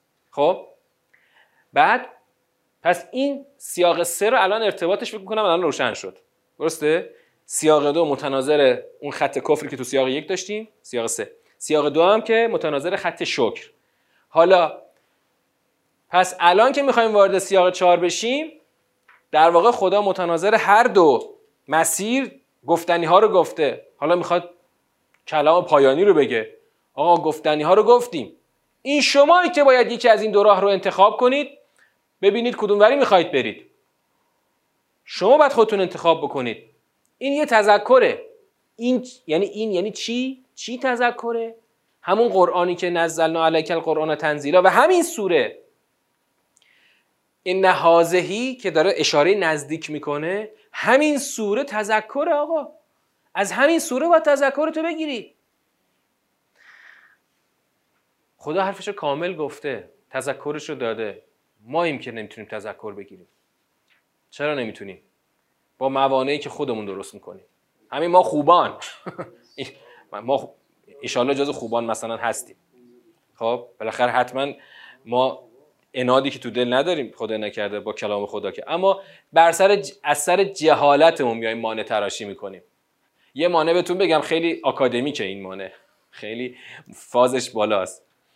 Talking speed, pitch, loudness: 135 wpm, 185 Hz, -19 LUFS